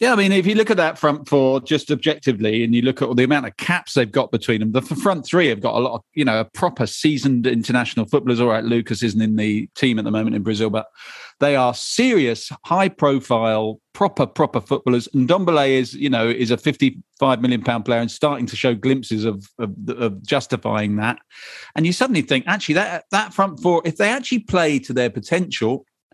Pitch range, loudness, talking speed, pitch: 115-155 Hz, -19 LUFS, 220 wpm, 130 Hz